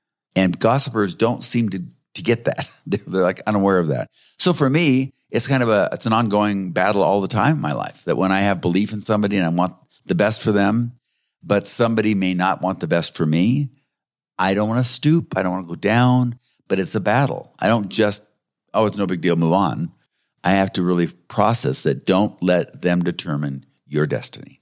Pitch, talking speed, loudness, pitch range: 100 Hz, 220 wpm, -20 LUFS, 90-115 Hz